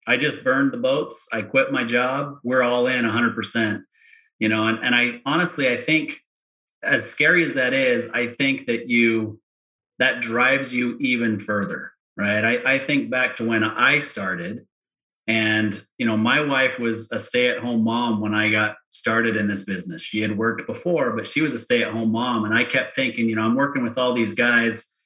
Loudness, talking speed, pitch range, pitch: -21 LUFS, 195 wpm, 110-130 Hz, 120 Hz